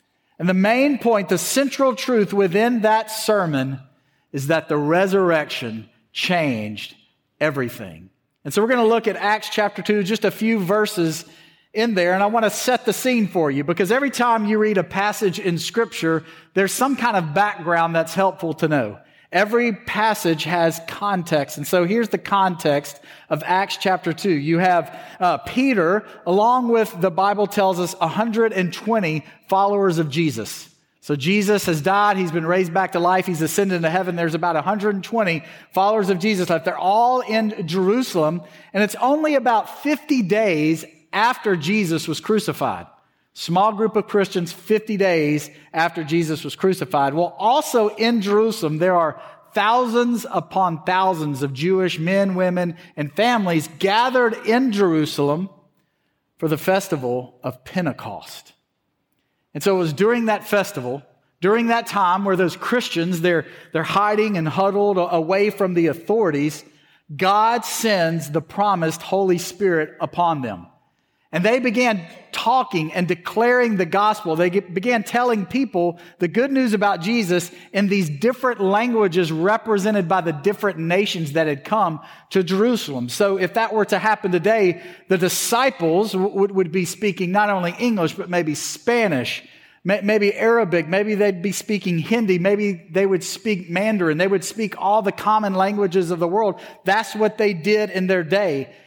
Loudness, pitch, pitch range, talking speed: -20 LUFS, 190 Hz, 165-215 Hz, 160 wpm